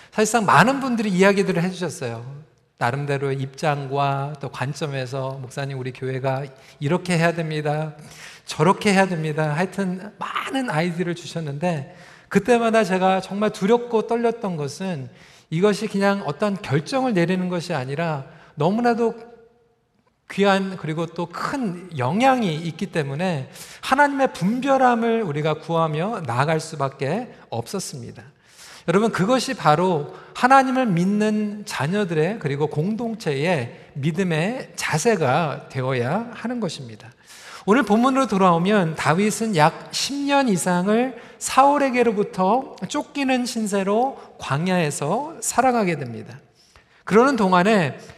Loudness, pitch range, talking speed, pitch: -21 LUFS, 150-220 Hz, 295 characters per minute, 180 Hz